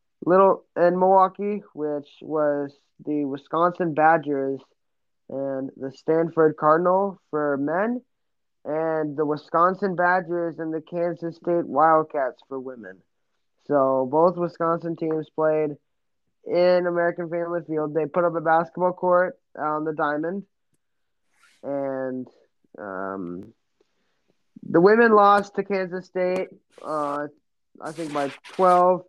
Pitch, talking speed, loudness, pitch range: 160 Hz, 115 wpm, -23 LUFS, 145-180 Hz